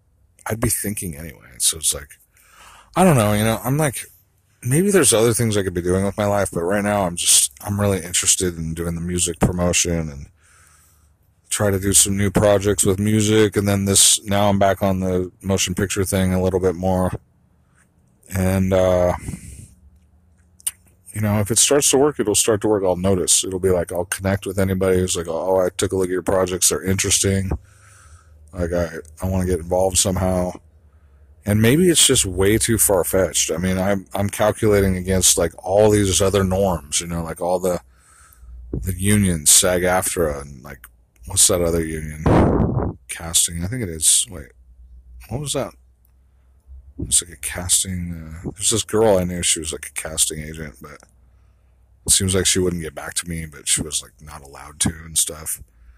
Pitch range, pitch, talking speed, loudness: 85-100 Hz, 95 Hz, 195 wpm, -18 LUFS